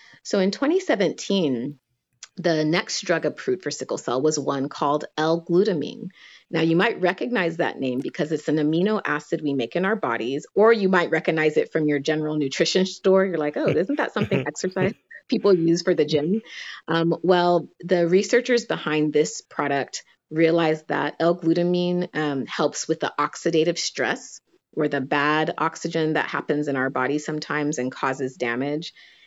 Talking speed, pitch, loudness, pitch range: 165 wpm, 160 Hz, -23 LUFS, 150-180 Hz